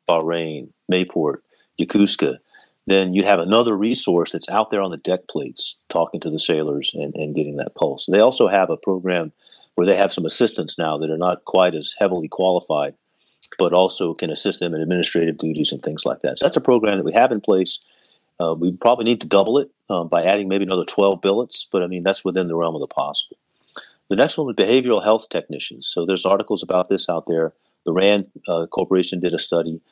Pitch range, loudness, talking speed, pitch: 80-95 Hz, -20 LUFS, 220 wpm, 90 Hz